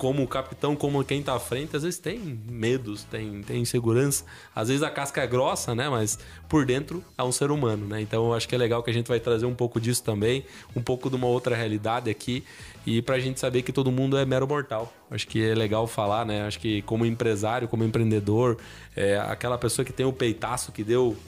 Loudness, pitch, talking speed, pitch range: -27 LUFS, 120 Hz, 235 wpm, 110-130 Hz